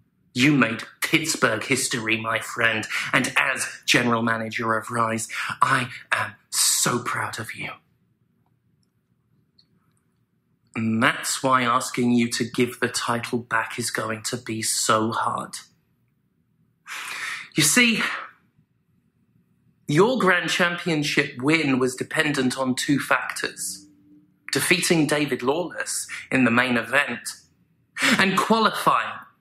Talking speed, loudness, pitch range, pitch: 110 wpm, -22 LUFS, 115-150 Hz, 125 Hz